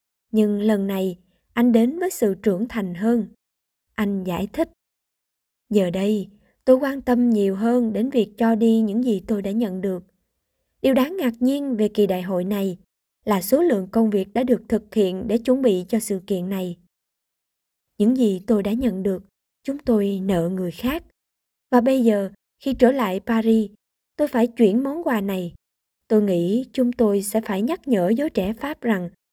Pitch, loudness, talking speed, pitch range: 220 Hz, -21 LUFS, 185 wpm, 195-240 Hz